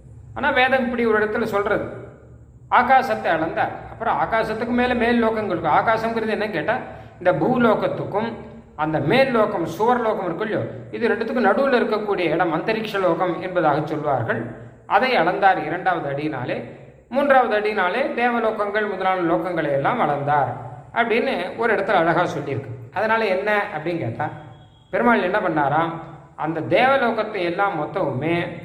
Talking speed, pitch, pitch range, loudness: 120 wpm, 195 Hz, 160-225 Hz, -21 LUFS